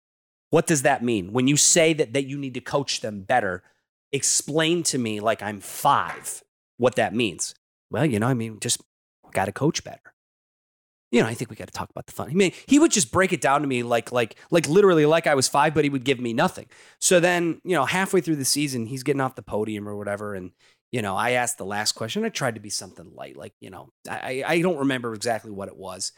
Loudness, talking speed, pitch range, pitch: -23 LUFS, 250 wpm, 115-160 Hz, 135 Hz